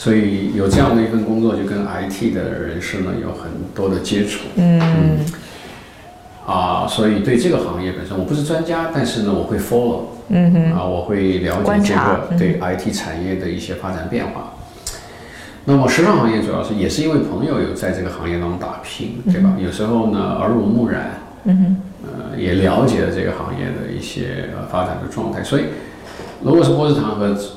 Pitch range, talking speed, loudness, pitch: 95-150 Hz, 295 characters per minute, -18 LUFS, 105 Hz